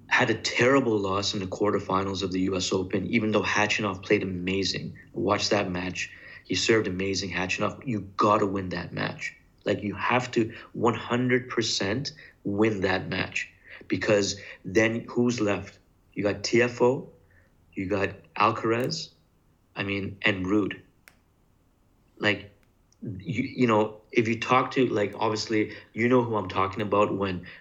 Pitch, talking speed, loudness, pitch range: 105 Hz, 145 wpm, -26 LUFS, 95-110 Hz